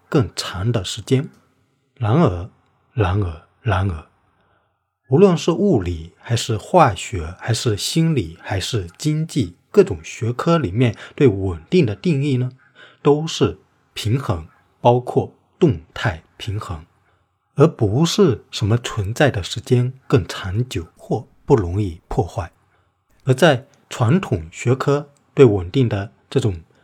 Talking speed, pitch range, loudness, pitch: 185 characters per minute, 100-135 Hz, -19 LUFS, 115 Hz